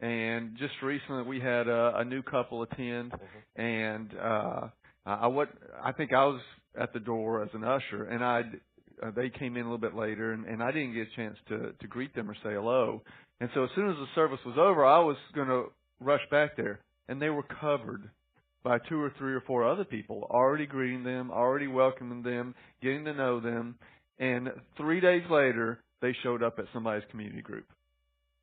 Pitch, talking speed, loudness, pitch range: 125 Hz, 205 wpm, -31 LUFS, 115-135 Hz